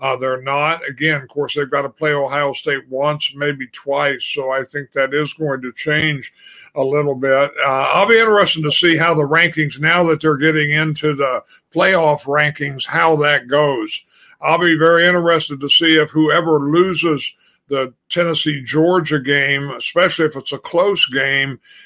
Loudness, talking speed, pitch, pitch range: -16 LUFS, 180 wpm, 150 Hz, 140-160 Hz